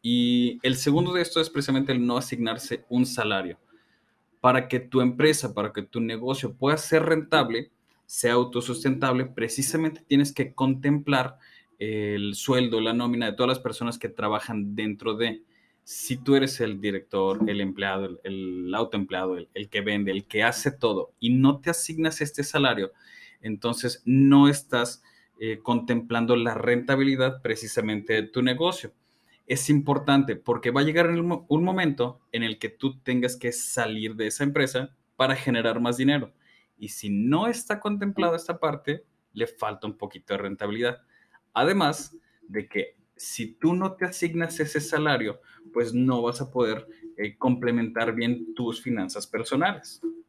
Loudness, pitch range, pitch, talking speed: -26 LUFS, 115-145 Hz, 125 Hz, 155 wpm